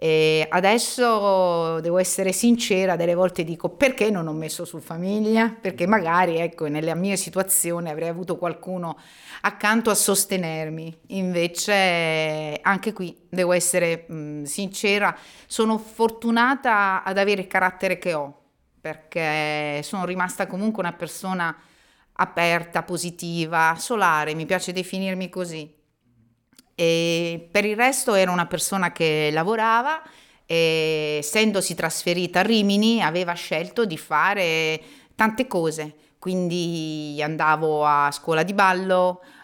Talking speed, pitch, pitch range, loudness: 120 wpm, 175 Hz, 160-195 Hz, -22 LUFS